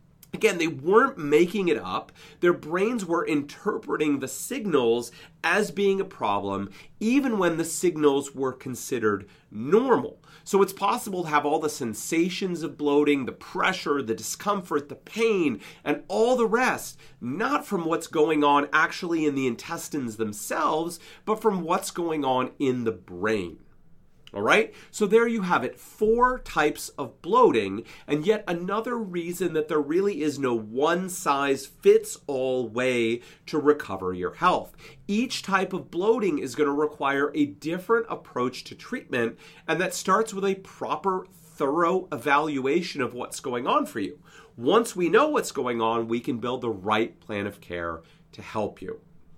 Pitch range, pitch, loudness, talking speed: 135-195 Hz, 160 Hz, -25 LUFS, 165 wpm